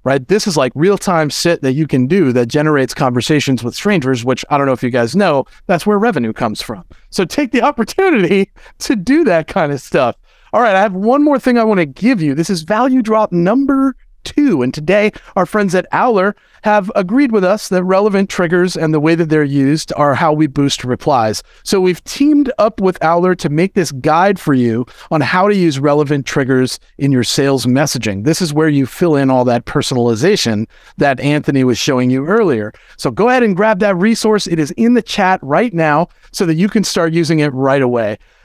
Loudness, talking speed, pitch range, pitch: -13 LUFS, 220 wpm, 140-210 Hz, 170 Hz